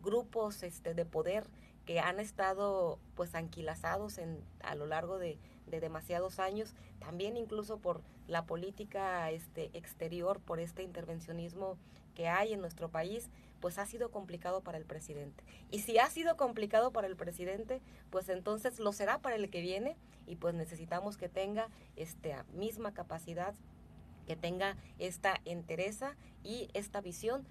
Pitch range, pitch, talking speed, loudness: 170-205 Hz, 185 Hz, 155 wpm, -39 LUFS